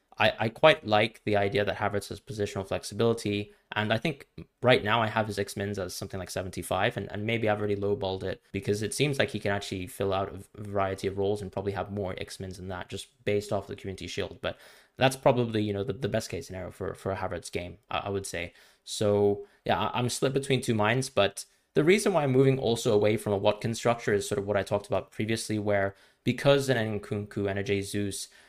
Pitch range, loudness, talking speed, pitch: 100-115 Hz, -29 LUFS, 230 wpm, 105 Hz